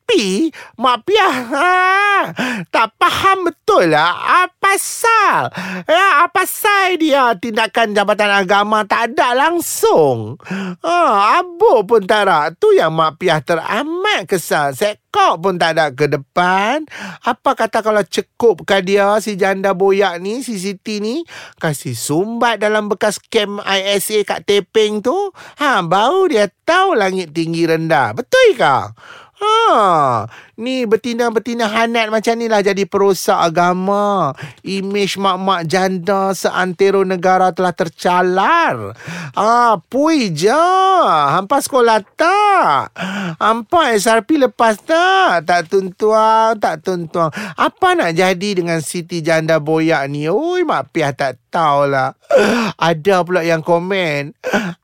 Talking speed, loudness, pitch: 125 wpm, -14 LUFS, 210 Hz